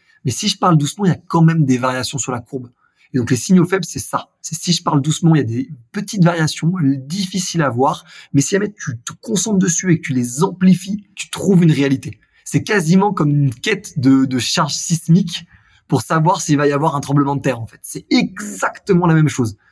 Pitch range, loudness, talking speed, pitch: 140-185 Hz, -16 LUFS, 240 wpm, 160 Hz